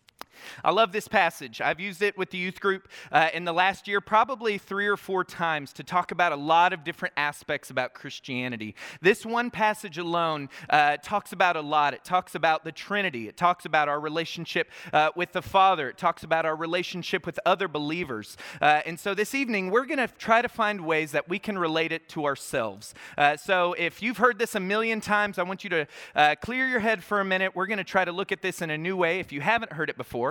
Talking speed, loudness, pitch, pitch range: 235 wpm, -26 LUFS, 180 Hz, 160-205 Hz